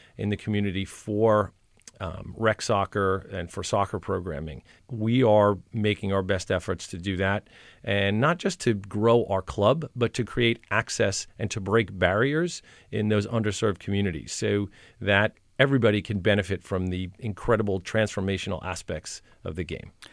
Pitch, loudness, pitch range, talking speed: 105 Hz, -26 LUFS, 95-110 Hz, 155 wpm